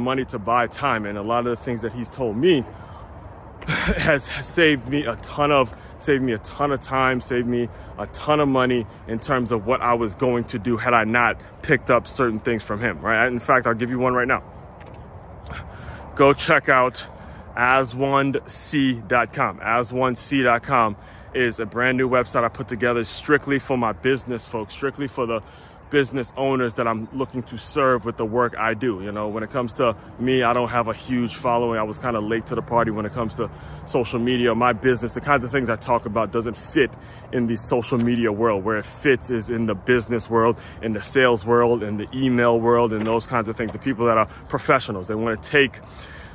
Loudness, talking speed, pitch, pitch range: -21 LUFS, 215 wpm, 120 Hz, 115-130 Hz